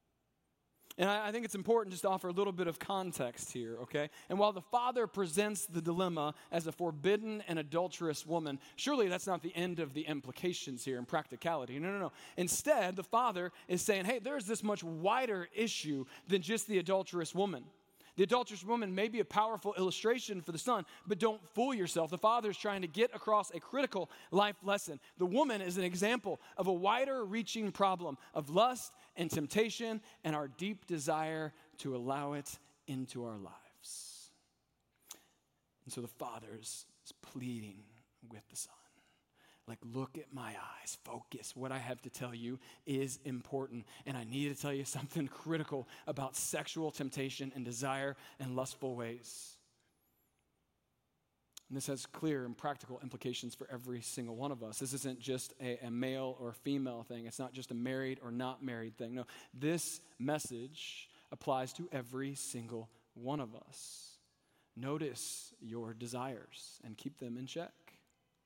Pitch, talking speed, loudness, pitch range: 150 Hz, 170 wpm, -38 LUFS, 130-190 Hz